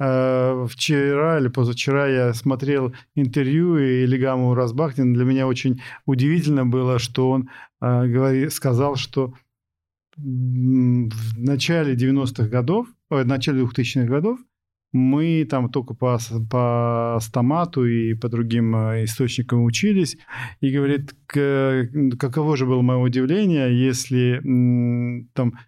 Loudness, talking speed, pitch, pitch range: -20 LUFS, 110 wpm, 130 Hz, 125-140 Hz